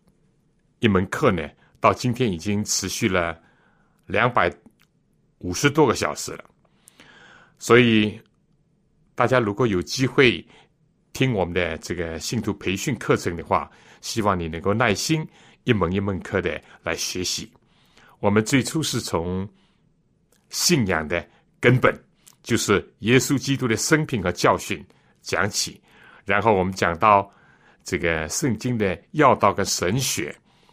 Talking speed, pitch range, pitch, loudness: 195 characters per minute, 90-130 Hz, 110 Hz, -22 LUFS